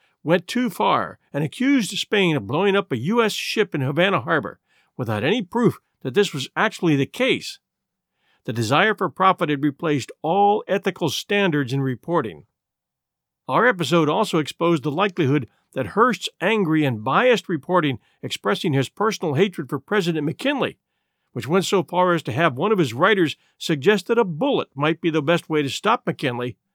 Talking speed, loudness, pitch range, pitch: 175 wpm, -21 LUFS, 150-205 Hz, 170 Hz